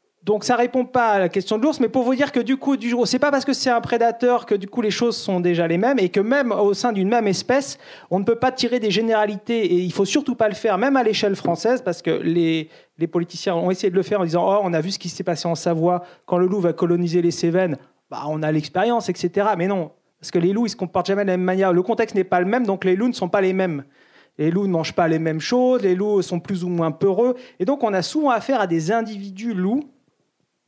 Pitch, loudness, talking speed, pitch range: 200 Hz, -20 LUFS, 295 wpm, 180-235 Hz